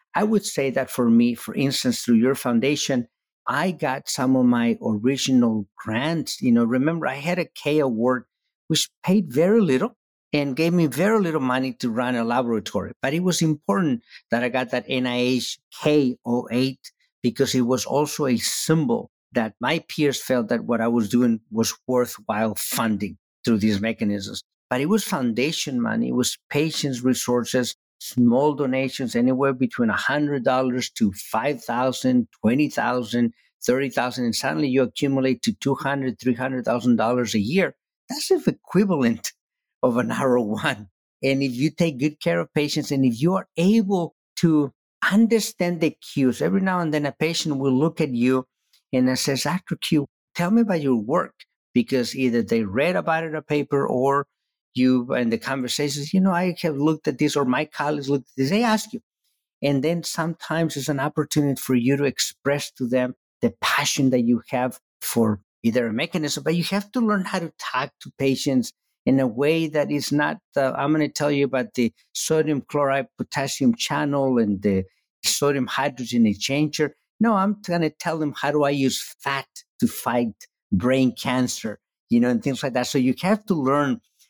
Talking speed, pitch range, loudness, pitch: 180 wpm, 125-160 Hz, -23 LUFS, 140 Hz